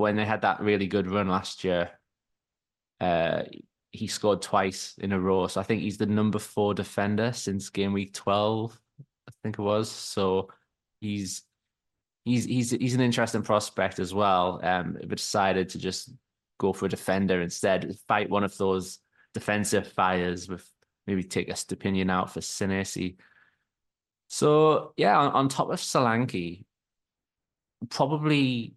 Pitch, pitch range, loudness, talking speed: 105 Hz, 95-115 Hz, -27 LUFS, 155 wpm